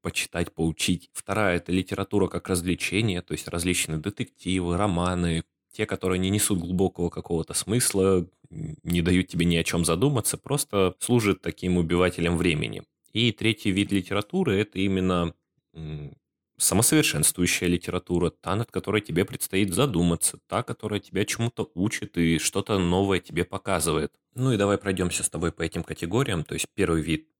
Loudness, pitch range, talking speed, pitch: -25 LUFS, 85-100 Hz, 150 wpm, 95 Hz